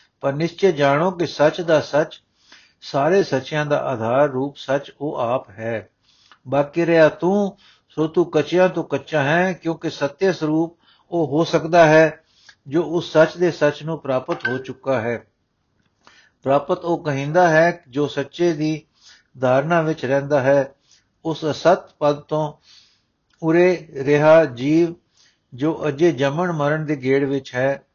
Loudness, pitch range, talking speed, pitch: -19 LUFS, 140-170 Hz, 145 wpm, 155 Hz